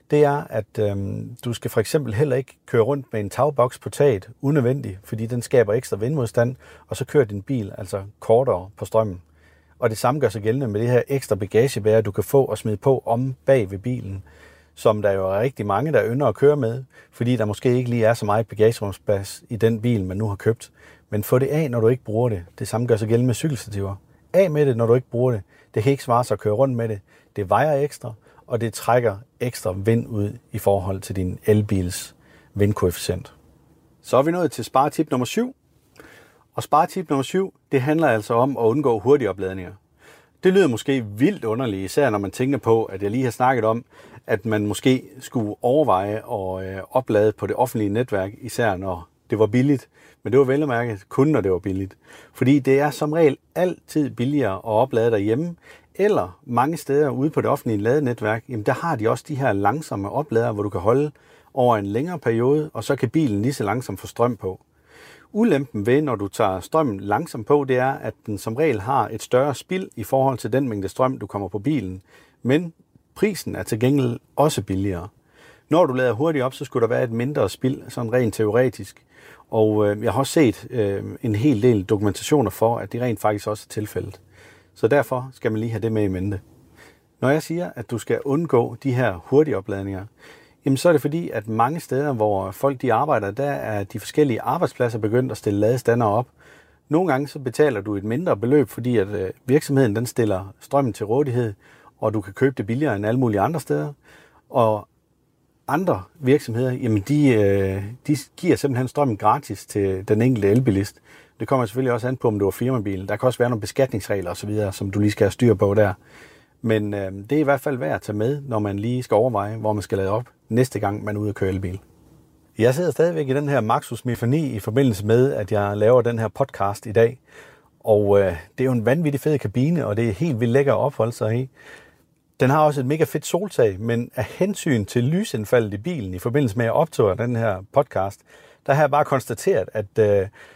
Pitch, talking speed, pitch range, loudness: 120 Hz, 215 wpm, 105-135 Hz, -21 LUFS